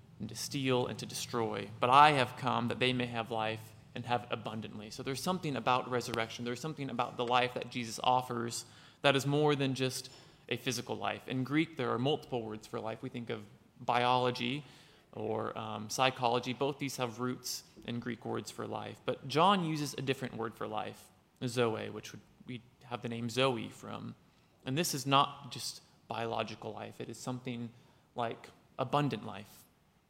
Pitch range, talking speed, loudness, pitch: 115-135 Hz, 185 wpm, -34 LUFS, 125 Hz